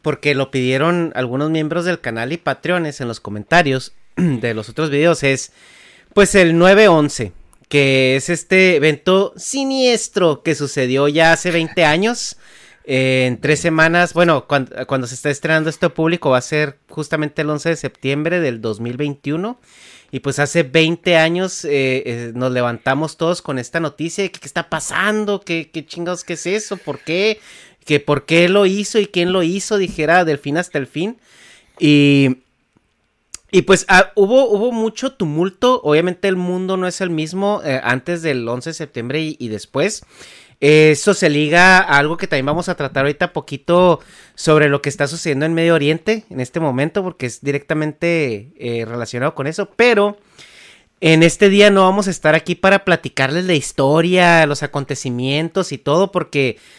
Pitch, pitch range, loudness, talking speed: 160 Hz, 140-180 Hz, -16 LUFS, 175 wpm